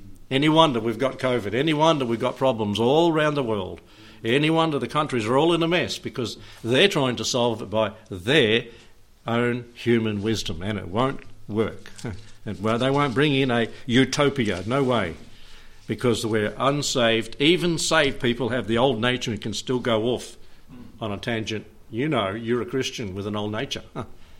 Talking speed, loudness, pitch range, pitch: 190 wpm, -23 LUFS, 110-135 Hz, 120 Hz